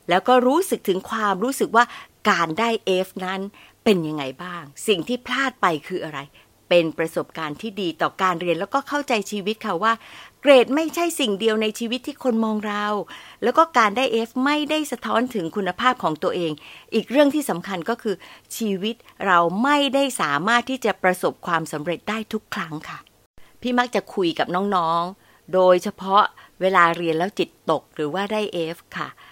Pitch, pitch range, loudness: 205 Hz, 175-240 Hz, -22 LUFS